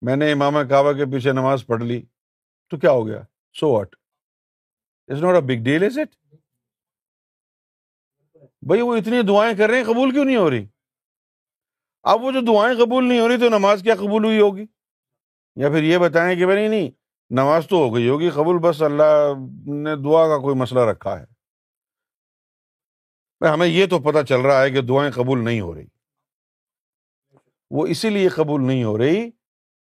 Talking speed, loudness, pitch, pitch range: 165 wpm, -18 LUFS, 150 Hz, 130-205 Hz